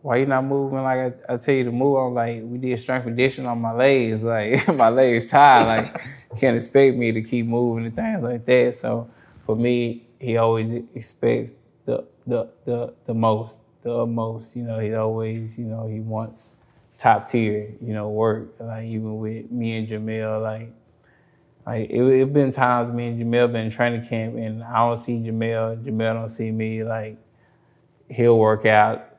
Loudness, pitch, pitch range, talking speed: -21 LUFS, 115 Hz, 110-125 Hz, 190 wpm